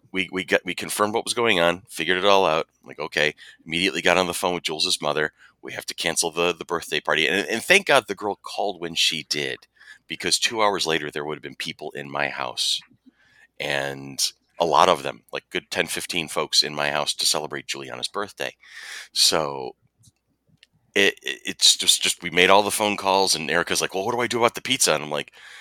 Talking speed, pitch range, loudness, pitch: 225 wpm, 75-100 Hz, -22 LUFS, 90 Hz